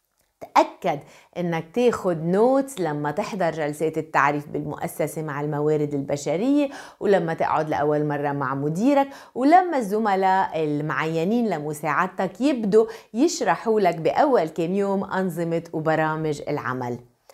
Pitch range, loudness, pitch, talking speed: 150-210 Hz, -23 LUFS, 165 Hz, 105 wpm